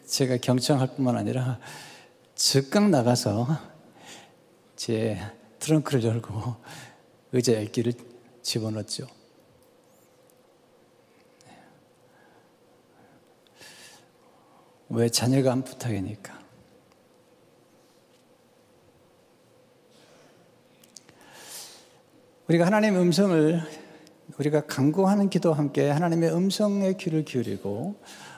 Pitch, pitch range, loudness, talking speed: 135 Hz, 120-160 Hz, -25 LUFS, 160 characters per minute